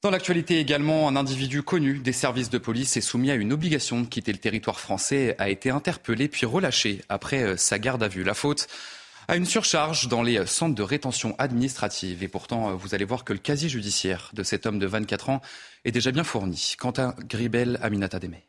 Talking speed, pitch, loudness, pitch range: 210 wpm, 125 Hz, -25 LUFS, 105-140 Hz